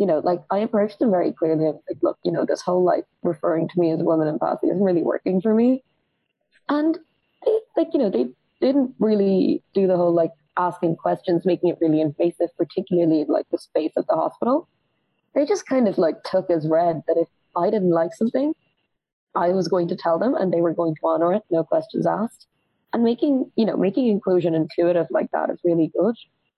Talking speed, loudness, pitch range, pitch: 220 wpm, -22 LUFS, 165-220 Hz, 175 Hz